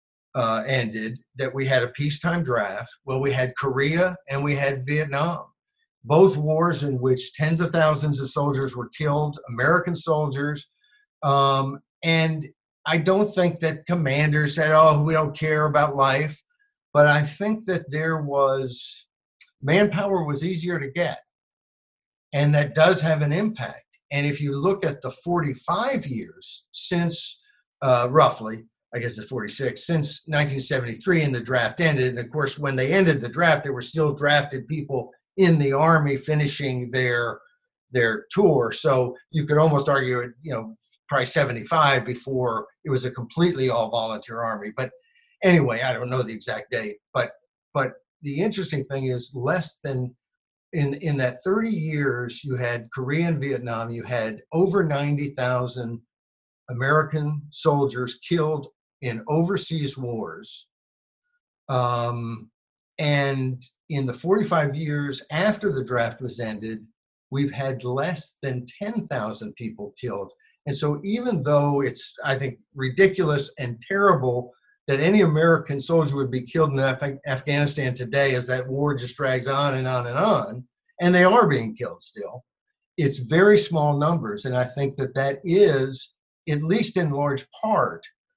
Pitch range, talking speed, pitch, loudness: 130-165 Hz, 150 wpm, 140 Hz, -23 LUFS